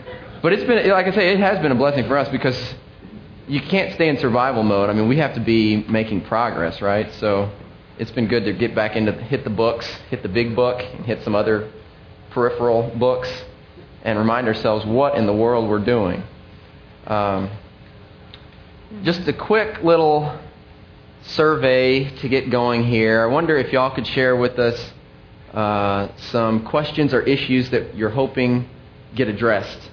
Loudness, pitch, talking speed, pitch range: -19 LUFS, 120 Hz, 170 wpm, 110-135 Hz